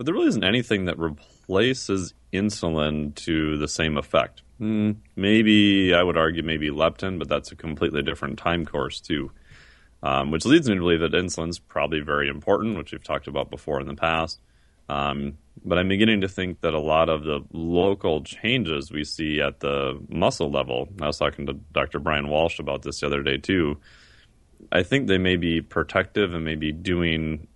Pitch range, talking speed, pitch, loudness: 75-90 Hz, 190 wpm, 80 Hz, -24 LUFS